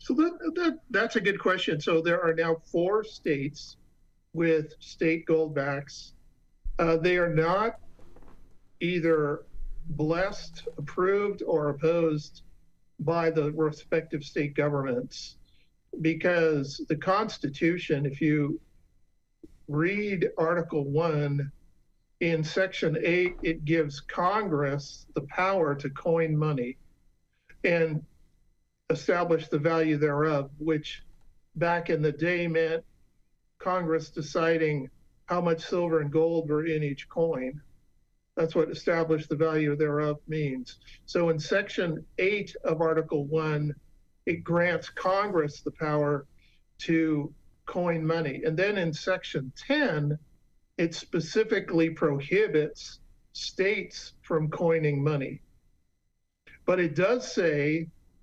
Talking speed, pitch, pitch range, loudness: 115 wpm, 160 Hz, 150-170 Hz, -28 LUFS